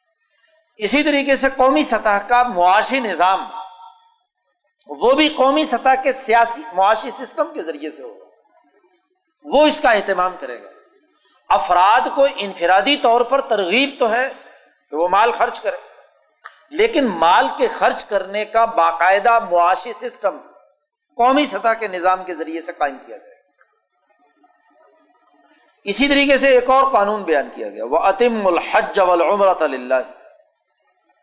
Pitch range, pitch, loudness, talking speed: 190-290 Hz, 245 Hz, -16 LUFS, 140 wpm